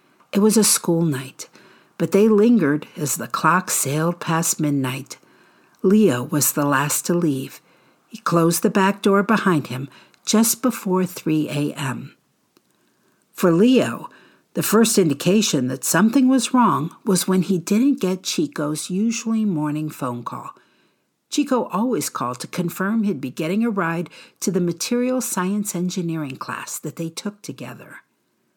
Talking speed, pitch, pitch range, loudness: 145 wpm, 180 Hz, 155-215 Hz, -20 LUFS